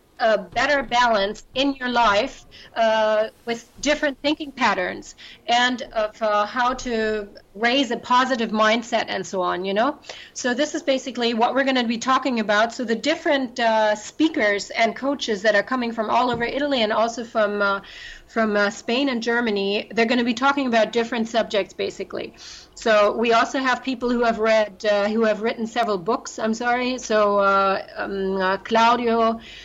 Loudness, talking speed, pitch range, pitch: -21 LUFS, 180 wpm, 215-255 Hz, 230 Hz